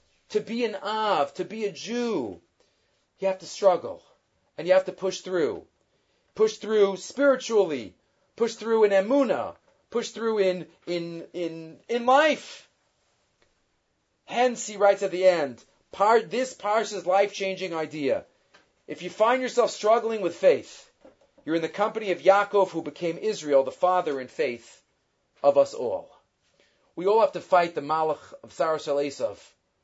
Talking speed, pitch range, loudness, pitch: 155 wpm, 170-220 Hz, -25 LUFS, 195 Hz